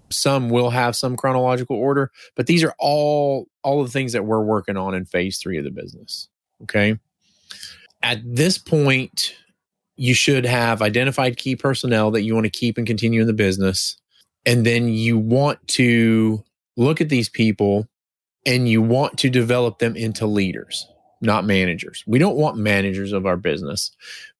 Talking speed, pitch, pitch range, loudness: 170 wpm, 120 Hz, 110-130 Hz, -19 LUFS